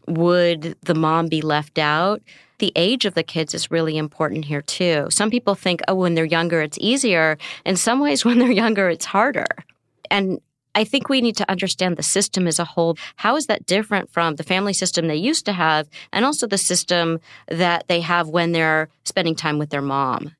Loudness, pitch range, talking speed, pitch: -19 LUFS, 160-200 Hz, 210 wpm, 175 Hz